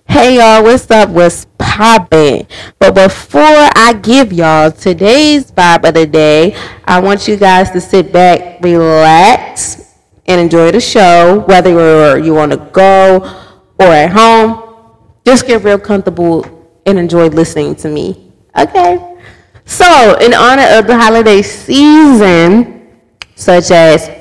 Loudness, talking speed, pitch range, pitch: -6 LUFS, 135 wpm, 165-225 Hz, 190 Hz